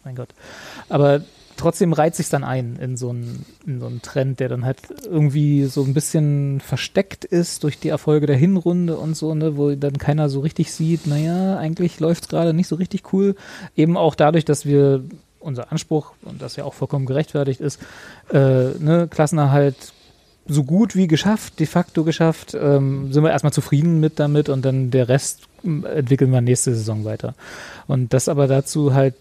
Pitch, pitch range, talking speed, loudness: 150 Hz, 135-165 Hz, 190 wpm, -19 LUFS